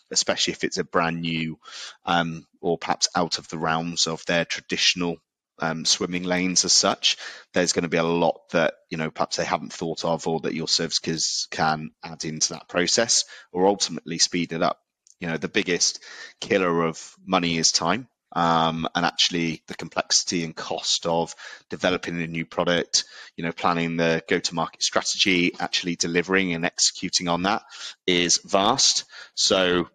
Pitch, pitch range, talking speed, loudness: 85 Hz, 80-90 Hz, 175 wpm, -23 LUFS